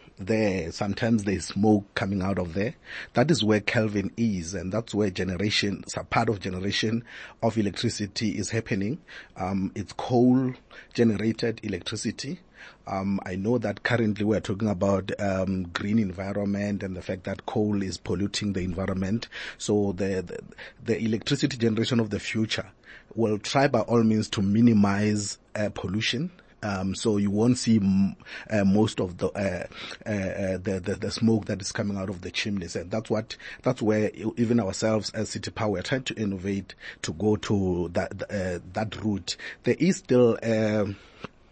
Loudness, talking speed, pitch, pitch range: -27 LUFS, 175 wpm, 105 Hz, 100-115 Hz